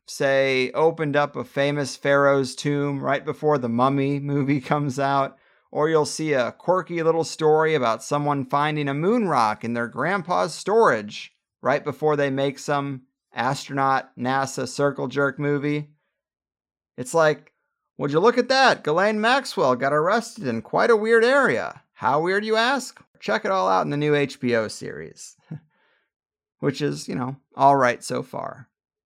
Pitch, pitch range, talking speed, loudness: 145 Hz, 135-160 Hz, 160 wpm, -22 LUFS